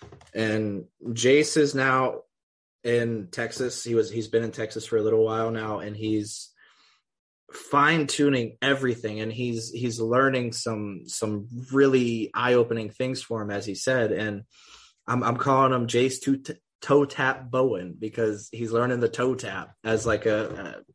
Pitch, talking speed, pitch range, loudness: 115 Hz, 165 wpm, 110-130 Hz, -25 LUFS